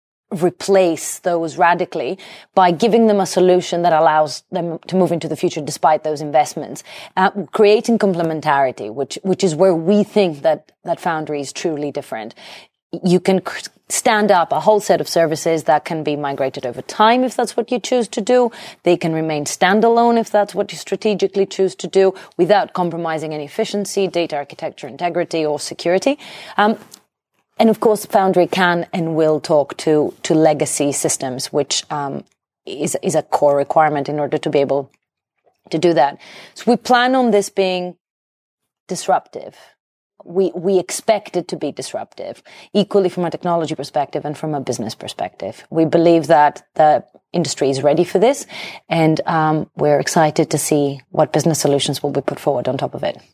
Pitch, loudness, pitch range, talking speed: 170 Hz, -17 LUFS, 150-195 Hz, 175 wpm